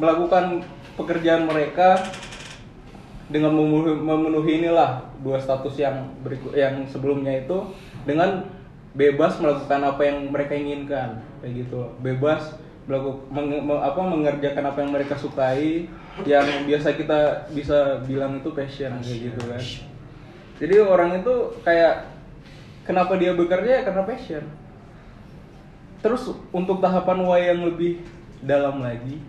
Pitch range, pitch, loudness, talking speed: 140-170 Hz, 145 Hz, -22 LUFS, 120 wpm